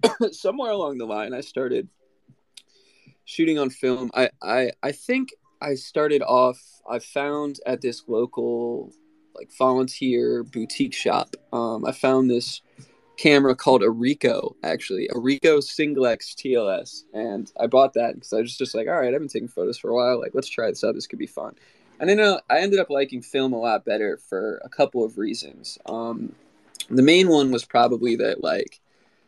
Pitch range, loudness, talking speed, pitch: 125-200 Hz, -23 LUFS, 185 wpm, 135 Hz